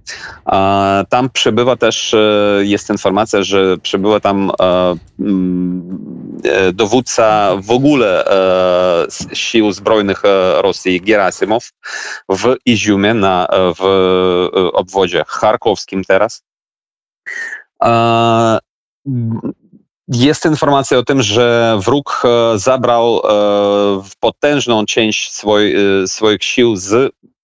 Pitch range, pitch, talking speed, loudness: 95-115 Hz, 105 Hz, 70 wpm, -13 LUFS